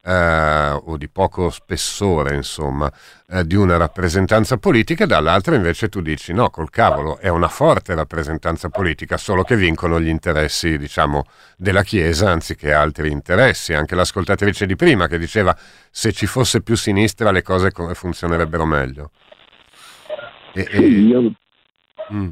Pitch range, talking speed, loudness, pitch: 80-100 Hz, 140 wpm, -17 LUFS, 90 Hz